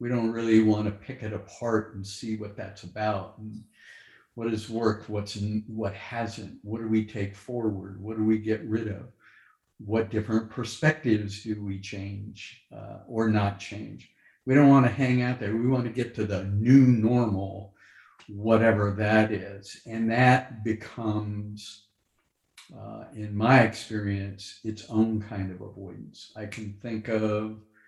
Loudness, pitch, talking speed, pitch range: -27 LUFS, 110 Hz, 160 wpm, 105-115 Hz